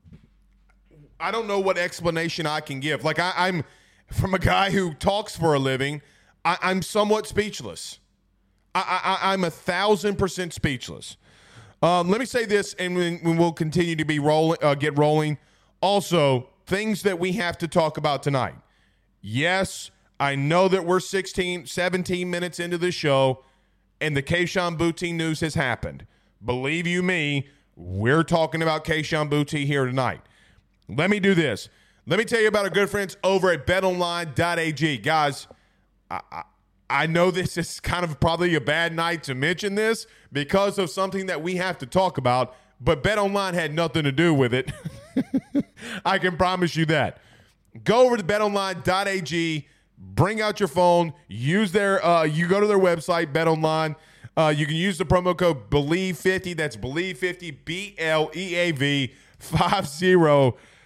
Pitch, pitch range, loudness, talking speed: 170 Hz, 145-185 Hz, -23 LUFS, 170 wpm